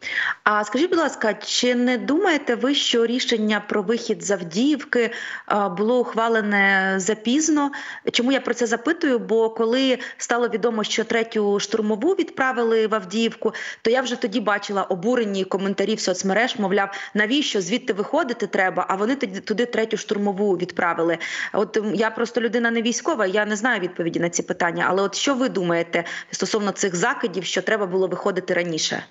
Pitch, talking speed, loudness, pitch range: 220 Hz, 160 wpm, -22 LUFS, 195-245 Hz